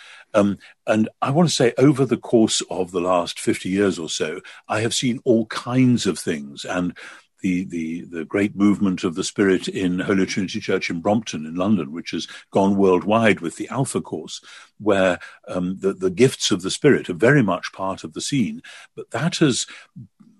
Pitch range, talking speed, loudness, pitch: 95-125 Hz, 195 wpm, -21 LUFS, 100 Hz